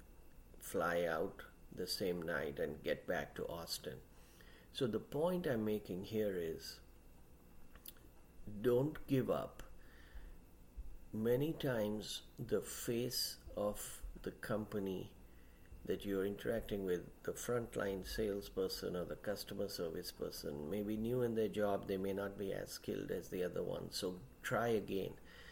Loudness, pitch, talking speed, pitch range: -41 LUFS, 100 Hz, 135 wpm, 75-110 Hz